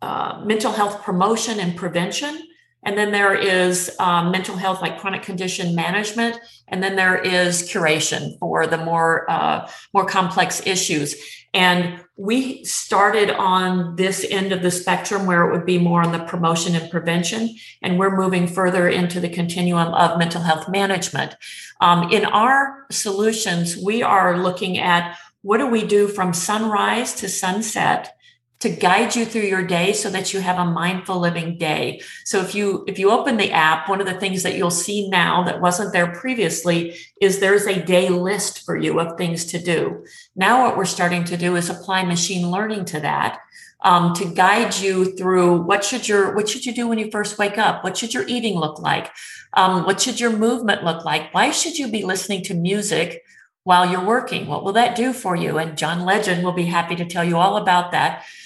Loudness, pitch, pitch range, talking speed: -19 LUFS, 185 Hz, 175-205 Hz, 195 wpm